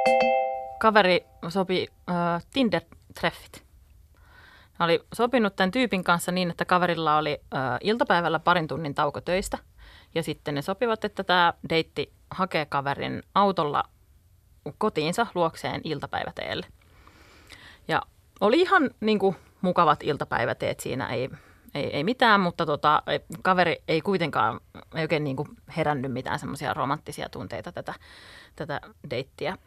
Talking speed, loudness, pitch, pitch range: 125 wpm, -26 LUFS, 165 Hz, 140-190 Hz